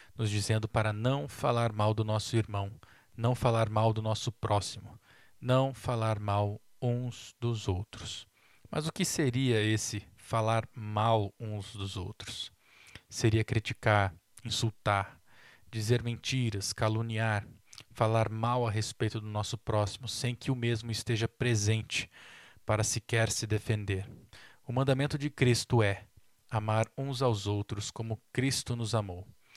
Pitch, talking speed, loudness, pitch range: 110 Hz, 135 wpm, -32 LUFS, 105-120 Hz